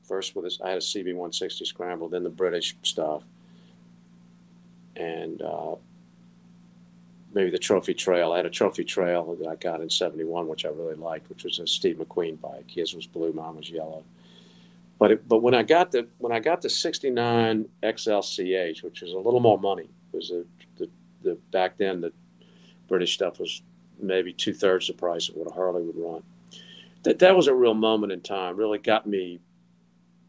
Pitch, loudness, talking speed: 125 Hz, -26 LUFS, 190 wpm